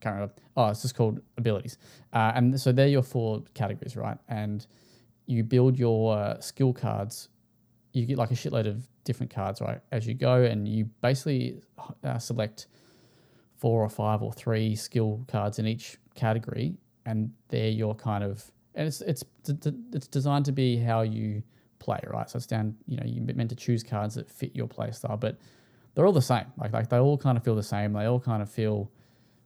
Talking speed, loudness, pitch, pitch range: 200 wpm, -29 LUFS, 115 Hz, 110-125 Hz